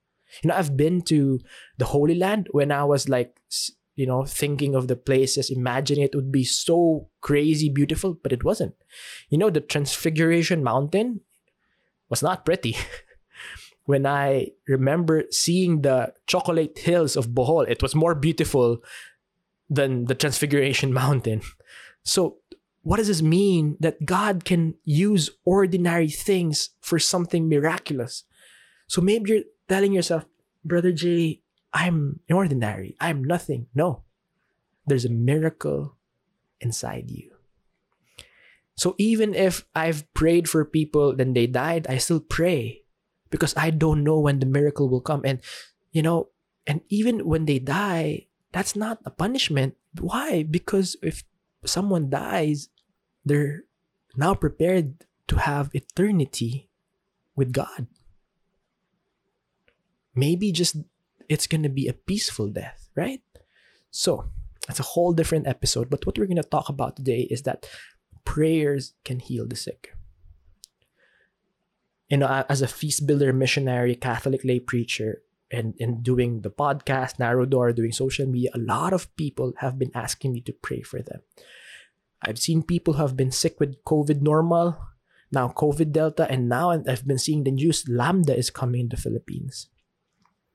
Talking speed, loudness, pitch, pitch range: 145 wpm, -24 LUFS, 150 Hz, 130-170 Hz